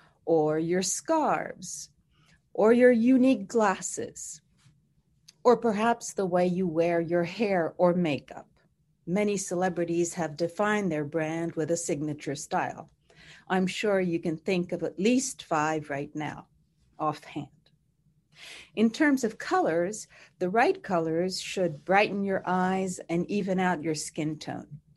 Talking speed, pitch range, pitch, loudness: 135 wpm, 155-195 Hz, 170 Hz, -27 LUFS